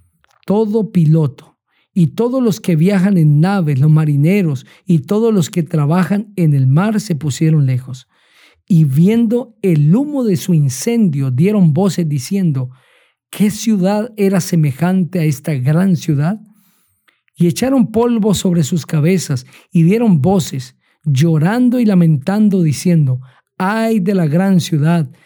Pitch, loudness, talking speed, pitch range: 175 Hz, -14 LUFS, 140 wpm, 155-200 Hz